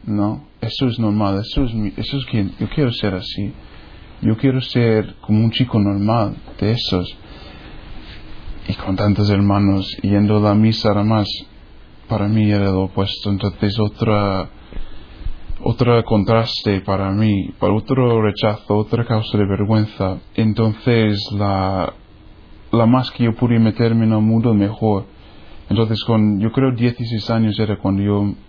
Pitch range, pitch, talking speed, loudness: 100-115 Hz, 105 Hz, 155 wpm, -18 LUFS